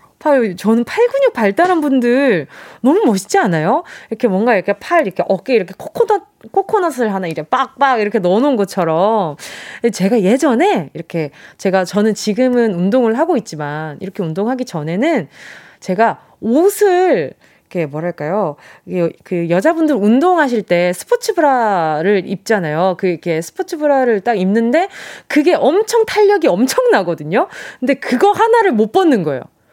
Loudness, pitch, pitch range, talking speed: -15 LUFS, 230 Hz, 190-310 Hz, 330 characters per minute